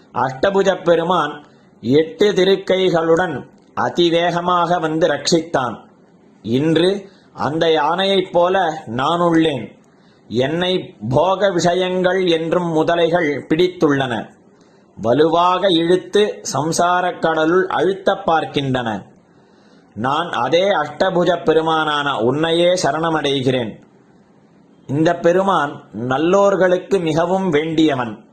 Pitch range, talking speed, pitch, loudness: 155-180 Hz, 75 wpm, 170 Hz, -17 LUFS